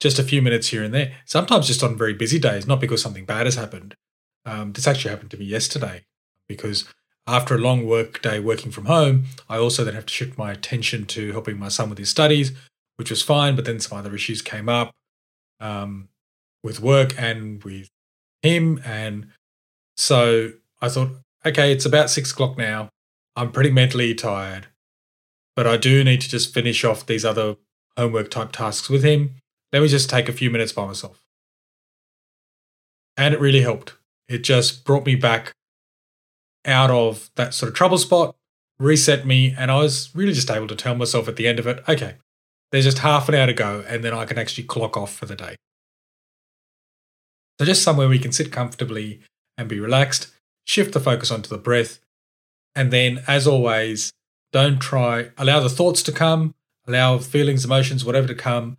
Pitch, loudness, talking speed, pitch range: 120 Hz, -20 LUFS, 190 wpm, 110-135 Hz